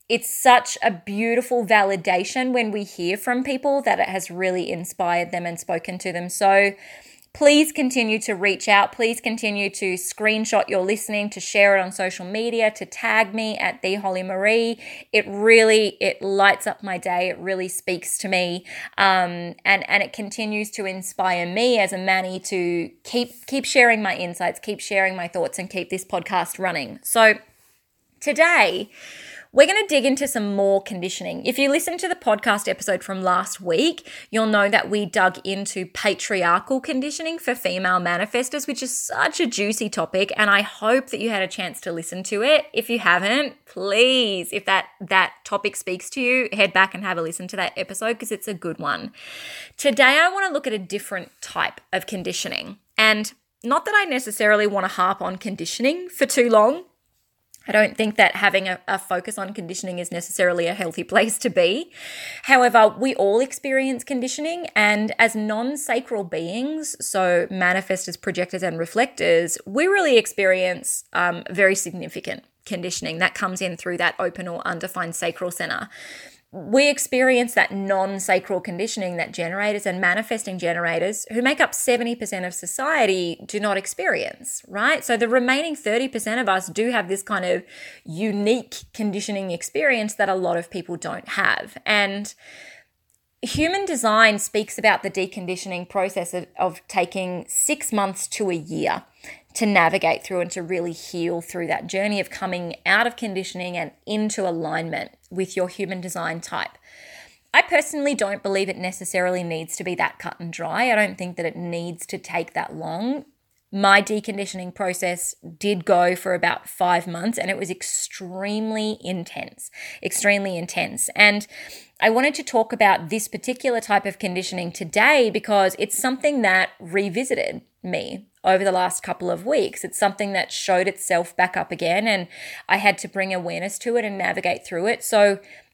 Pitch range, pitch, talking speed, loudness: 185-230 Hz, 200 Hz, 175 wpm, -21 LUFS